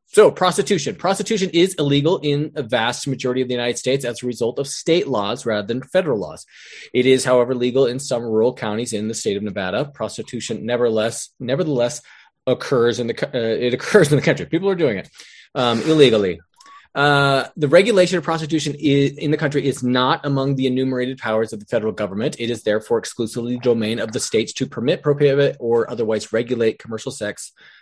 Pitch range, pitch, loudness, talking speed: 120-150 Hz, 130 Hz, -19 LUFS, 195 wpm